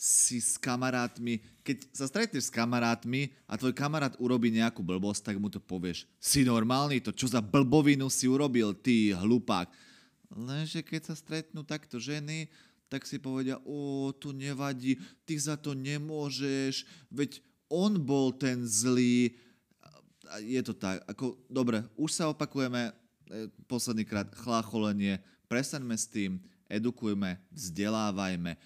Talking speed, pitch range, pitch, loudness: 140 wpm, 110-140 Hz, 125 Hz, -31 LUFS